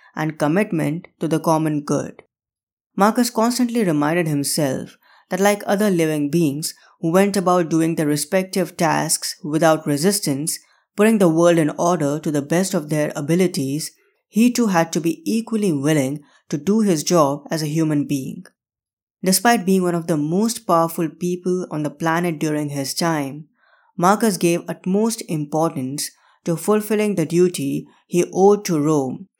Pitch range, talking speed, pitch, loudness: 155-190 Hz, 155 wpm, 165 Hz, -19 LUFS